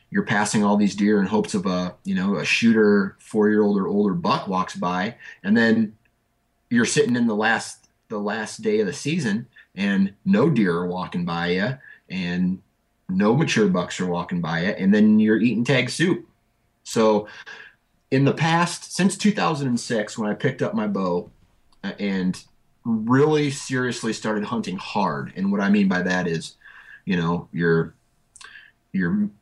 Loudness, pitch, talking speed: -22 LUFS, 115 Hz, 170 wpm